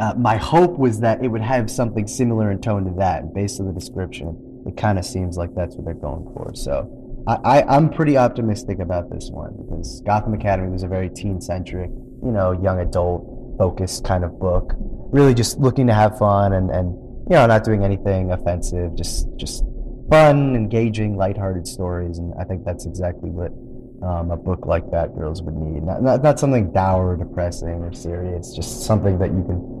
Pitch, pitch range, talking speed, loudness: 95 Hz, 90-120 Hz, 200 wpm, -20 LUFS